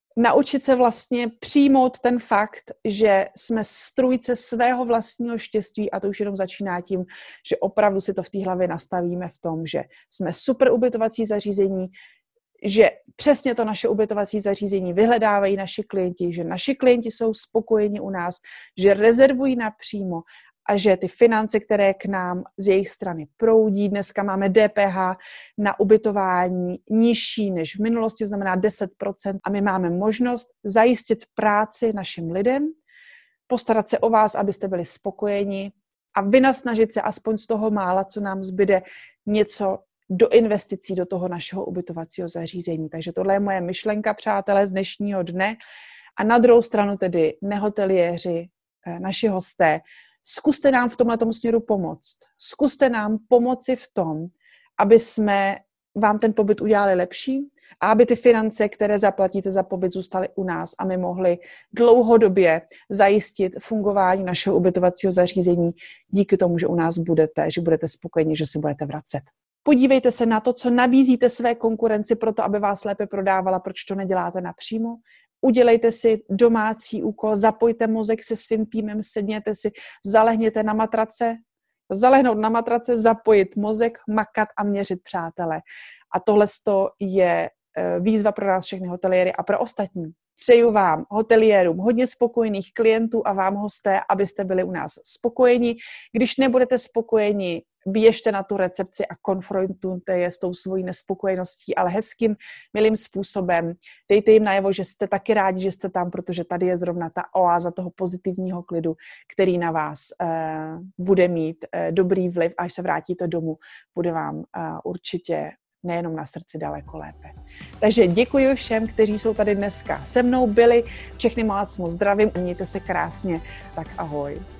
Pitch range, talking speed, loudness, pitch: 185-225 Hz, 155 wpm, -21 LUFS, 205 Hz